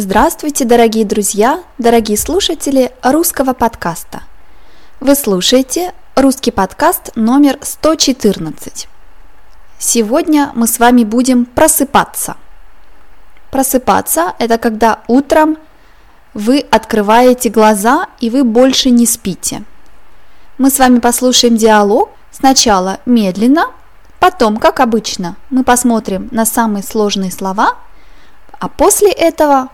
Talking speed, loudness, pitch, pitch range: 100 wpm, -11 LUFS, 245 Hz, 225-280 Hz